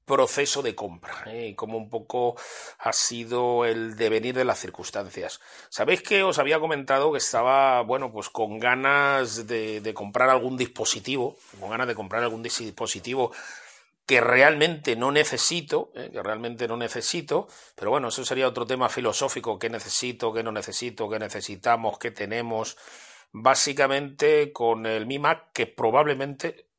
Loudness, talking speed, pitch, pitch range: -24 LUFS, 155 wpm, 120 Hz, 115-140 Hz